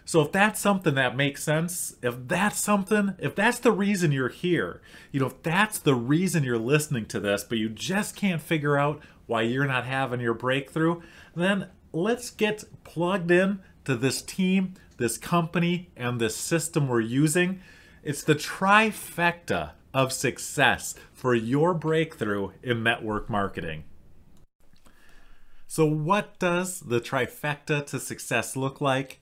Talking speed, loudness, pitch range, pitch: 150 wpm, -26 LUFS, 125-180 Hz, 150 Hz